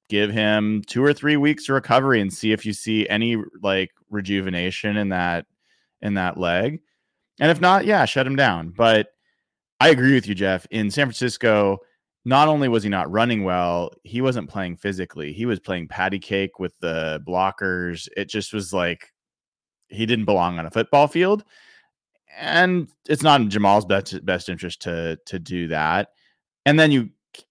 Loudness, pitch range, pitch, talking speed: -21 LUFS, 95-130 Hz, 105 Hz, 180 wpm